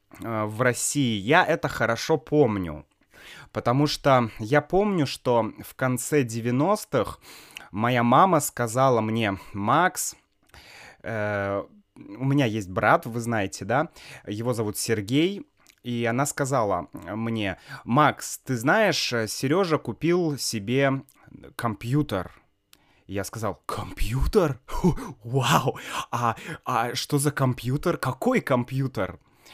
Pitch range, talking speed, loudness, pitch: 110-145 Hz, 105 wpm, -25 LUFS, 125 Hz